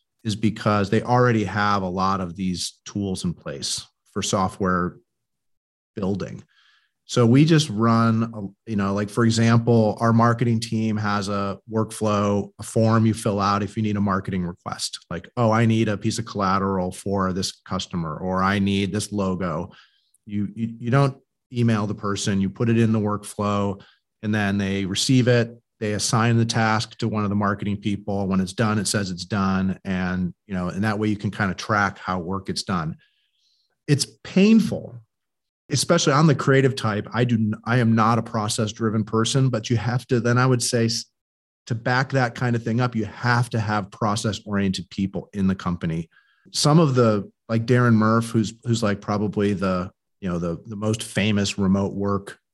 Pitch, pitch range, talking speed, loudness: 105 Hz, 100-115 Hz, 190 wpm, -22 LUFS